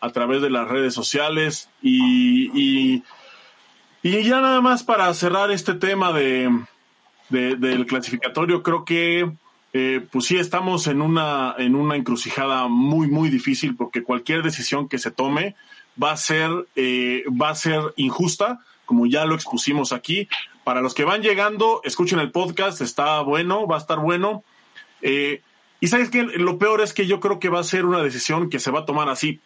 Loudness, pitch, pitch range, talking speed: -20 LUFS, 160 Hz, 135-200 Hz, 180 wpm